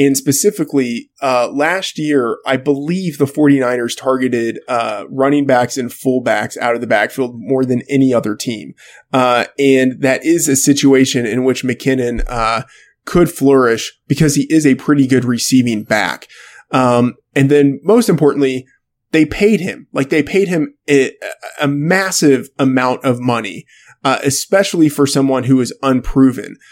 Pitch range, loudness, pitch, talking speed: 125-145 Hz, -14 LUFS, 135 Hz, 155 wpm